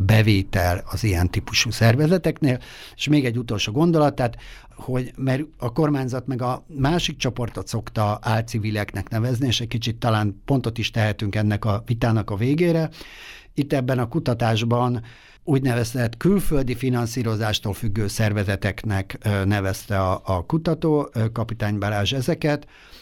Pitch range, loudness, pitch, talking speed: 105-135 Hz, -23 LUFS, 120 Hz, 135 wpm